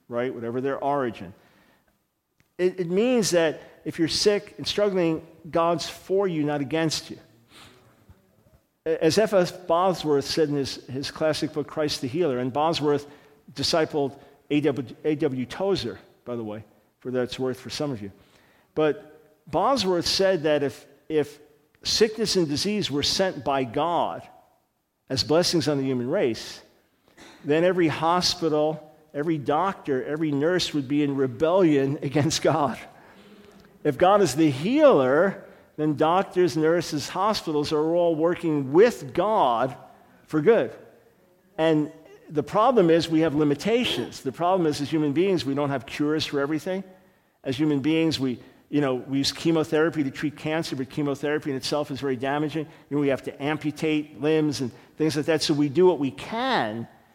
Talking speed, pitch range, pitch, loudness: 160 wpm, 140-170 Hz, 155 Hz, -24 LUFS